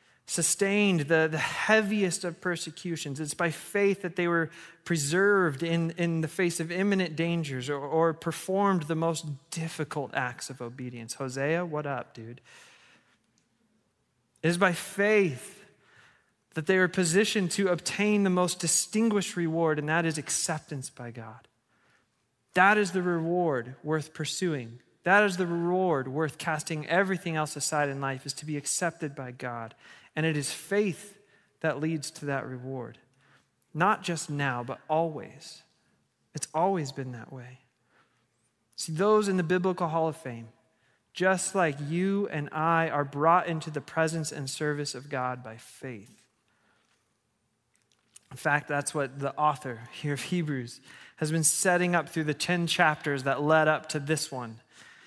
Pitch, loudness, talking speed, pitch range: 160 Hz, -28 LUFS, 155 wpm, 135-175 Hz